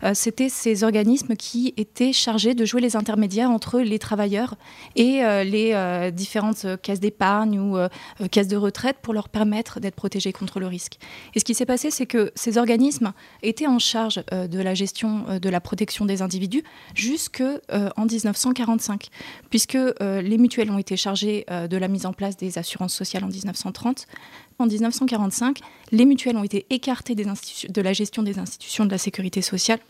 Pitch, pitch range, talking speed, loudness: 215 Hz, 195-240 Hz, 195 wpm, -23 LUFS